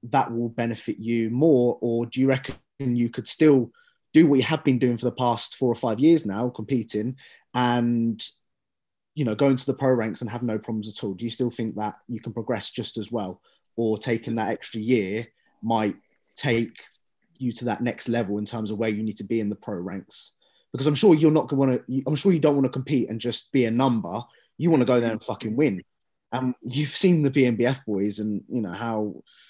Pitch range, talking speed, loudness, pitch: 110-130 Hz, 235 wpm, -24 LUFS, 120 Hz